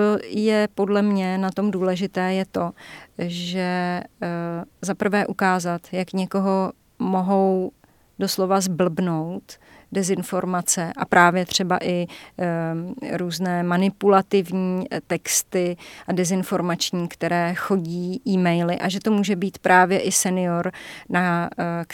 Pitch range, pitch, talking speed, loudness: 175-195 Hz, 185 Hz, 105 wpm, -22 LUFS